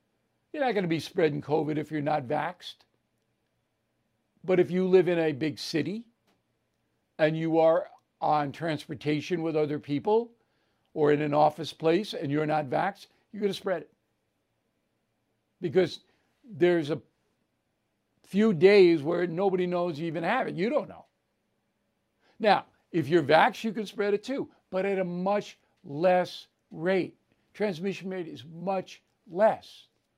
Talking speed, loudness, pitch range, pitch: 150 wpm, -27 LUFS, 145-185 Hz, 160 Hz